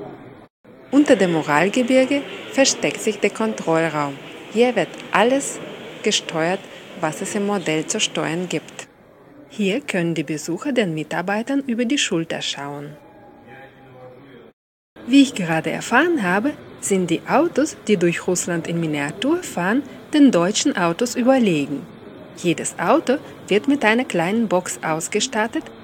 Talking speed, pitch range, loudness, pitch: 125 wpm, 160-245 Hz, -20 LUFS, 195 Hz